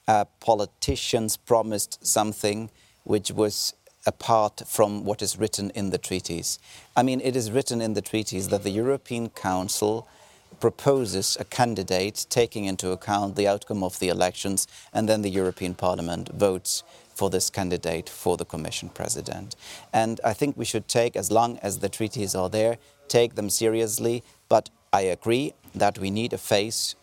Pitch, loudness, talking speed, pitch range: 105 Hz, -25 LUFS, 165 wpm, 95-115 Hz